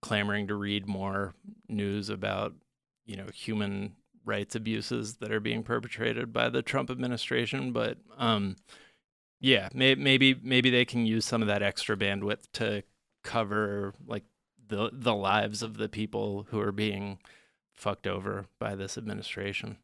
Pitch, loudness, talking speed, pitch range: 105 Hz, -30 LUFS, 150 wpm, 100-115 Hz